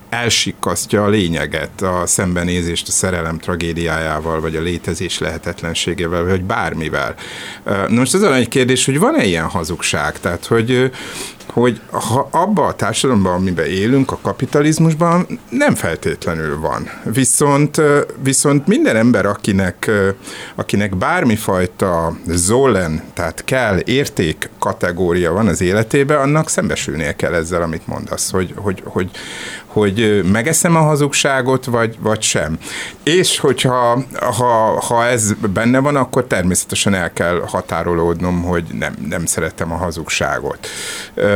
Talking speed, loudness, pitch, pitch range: 130 wpm, -16 LUFS, 105 Hz, 85-130 Hz